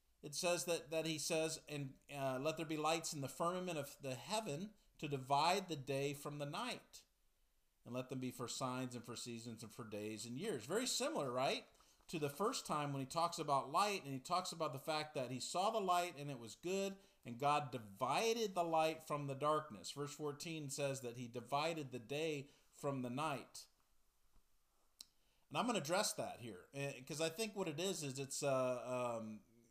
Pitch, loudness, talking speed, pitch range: 145 Hz, -42 LUFS, 210 wpm, 130-165 Hz